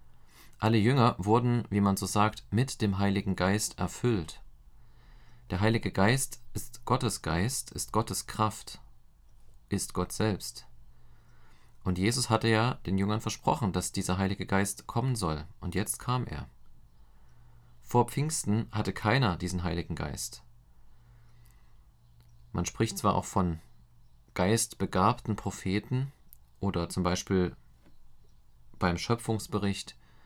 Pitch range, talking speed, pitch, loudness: 70-110 Hz, 120 wpm, 95 Hz, -30 LUFS